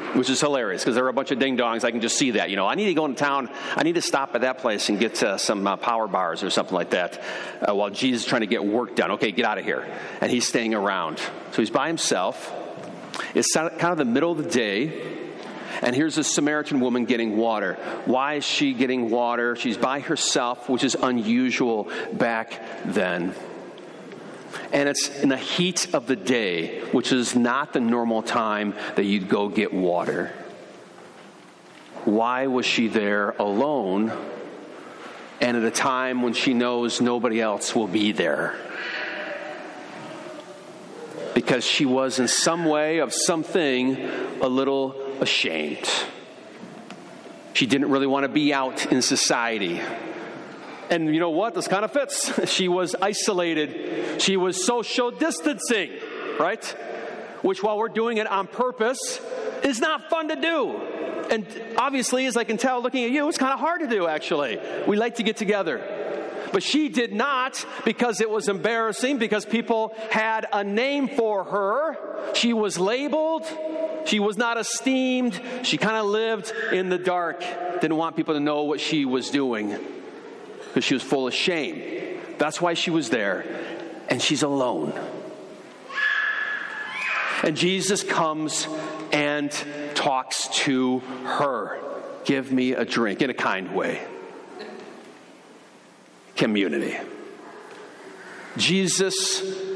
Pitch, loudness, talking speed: 180 Hz, -24 LUFS, 160 wpm